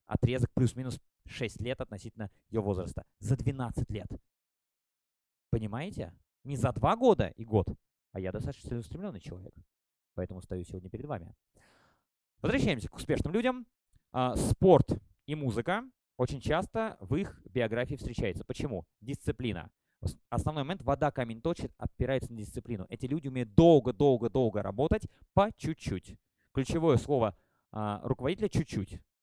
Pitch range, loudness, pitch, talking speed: 105-140 Hz, -32 LUFS, 125 Hz, 130 wpm